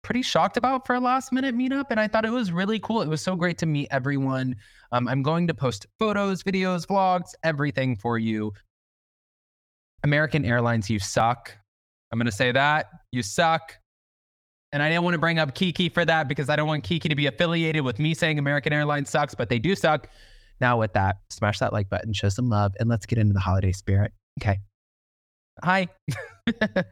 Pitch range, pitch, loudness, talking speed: 110-175 Hz, 145 Hz, -24 LUFS, 205 wpm